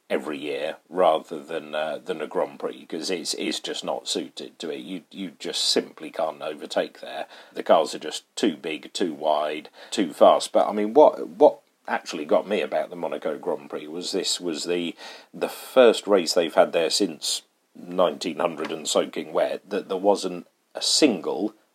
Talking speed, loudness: 190 wpm, -24 LUFS